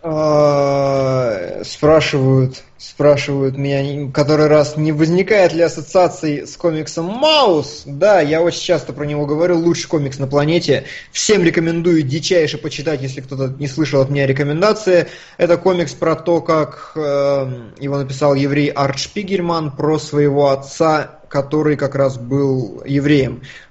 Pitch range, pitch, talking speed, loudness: 140-165 Hz, 150 Hz, 135 wpm, -16 LUFS